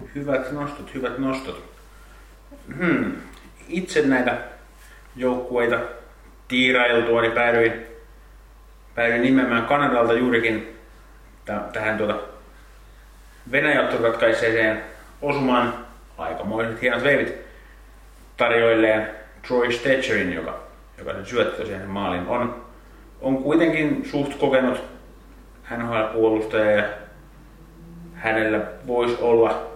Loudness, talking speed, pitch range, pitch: -22 LUFS, 90 wpm, 110-130 Hz, 120 Hz